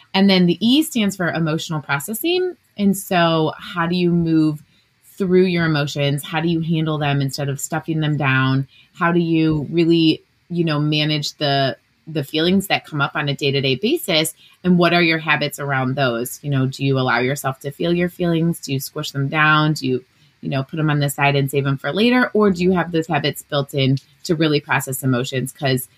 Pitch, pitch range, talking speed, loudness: 150 Hz, 140-170 Hz, 215 wpm, -19 LUFS